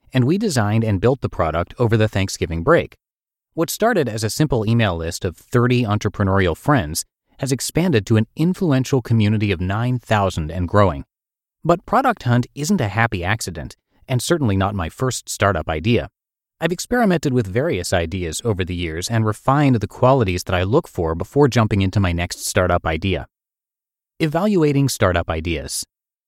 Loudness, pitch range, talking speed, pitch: -19 LUFS, 95-130 Hz, 165 wpm, 110 Hz